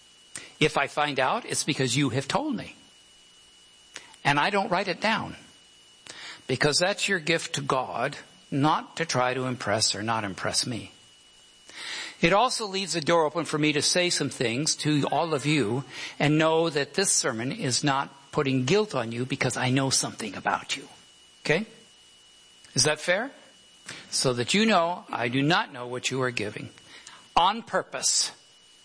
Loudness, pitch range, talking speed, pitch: -25 LUFS, 130-165 Hz, 170 wpm, 145 Hz